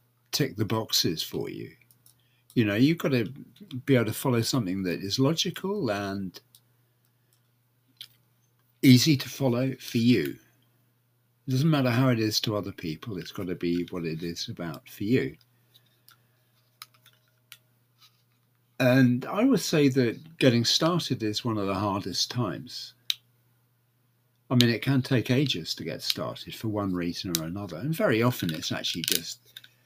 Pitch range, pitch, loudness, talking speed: 115-130 Hz, 120 Hz, -26 LUFS, 155 wpm